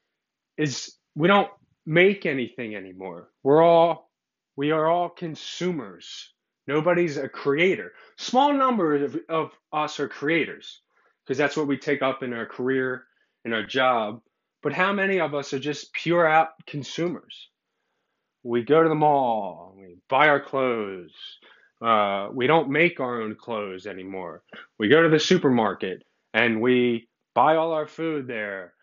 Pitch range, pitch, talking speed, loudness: 125-165 Hz, 145 Hz, 150 wpm, -23 LUFS